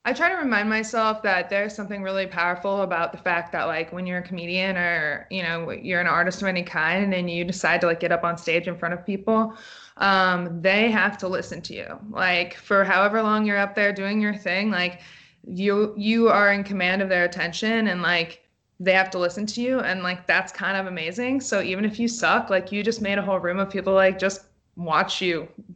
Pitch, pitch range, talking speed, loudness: 190 Hz, 175-205 Hz, 230 wpm, -23 LUFS